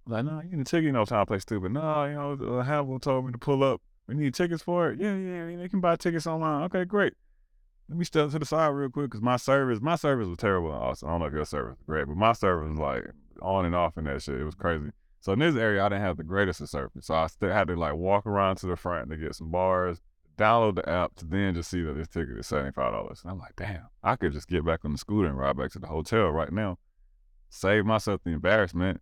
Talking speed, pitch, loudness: 285 wpm, 100 Hz, -28 LUFS